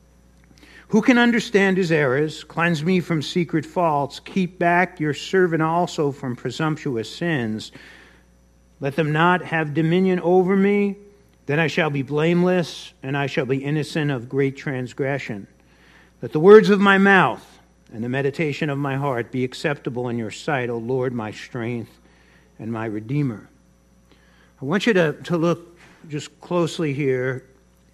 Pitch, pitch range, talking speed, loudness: 145 Hz, 120-175 Hz, 155 wpm, -21 LUFS